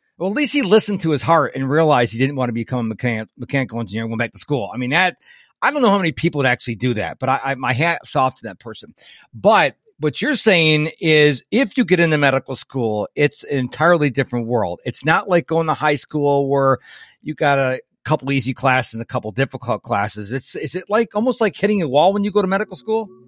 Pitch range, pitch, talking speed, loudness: 125-170 Hz, 140 Hz, 250 wpm, -18 LUFS